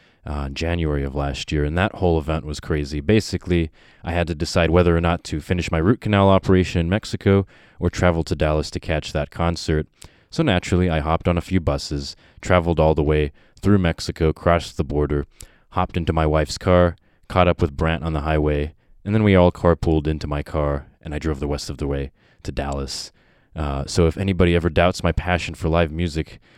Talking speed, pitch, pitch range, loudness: 210 wpm, 85 Hz, 75-90 Hz, -21 LUFS